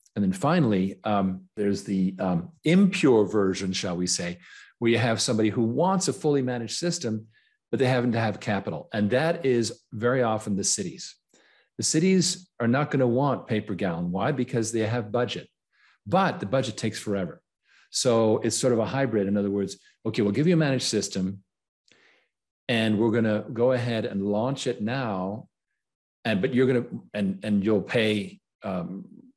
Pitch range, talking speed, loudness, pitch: 105-135 Hz, 185 wpm, -25 LUFS, 115 Hz